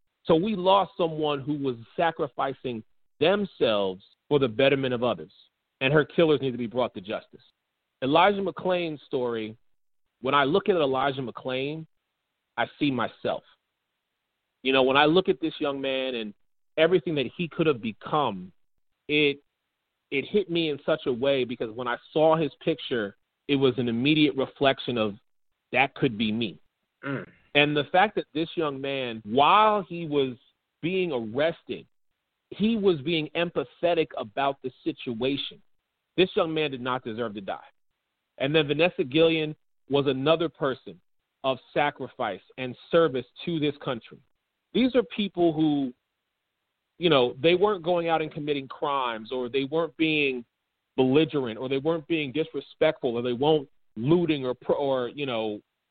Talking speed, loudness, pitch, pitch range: 160 wpm, -26 LUFS, 145 Hz, 130-165 Hz